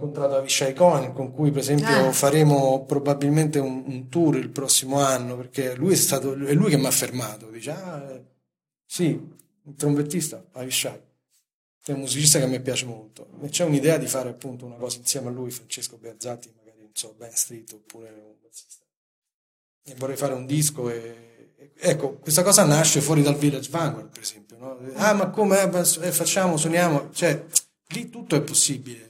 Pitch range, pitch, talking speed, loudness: 125-155 Hz, 140 Hz, 180 wpm, -22 LUFS